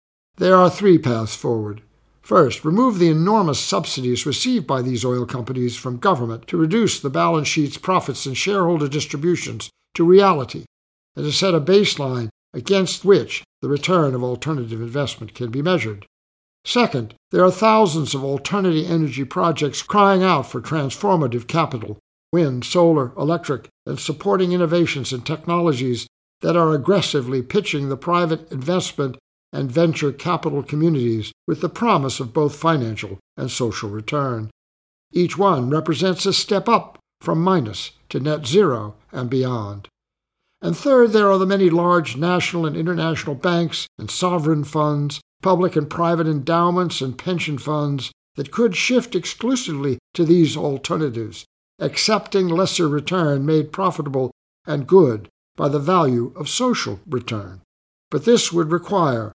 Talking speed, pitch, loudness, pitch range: 145 wpm, 155 Hz, -19 LUFS, 125-180 Hz